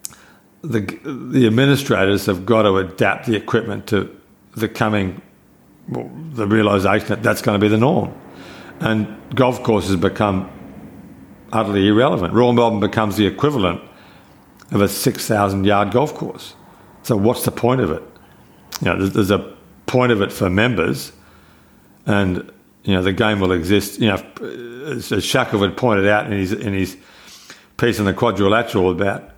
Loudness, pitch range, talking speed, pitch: -18 LUFS, 95-115 Hz, 155 wpm, 105 Hz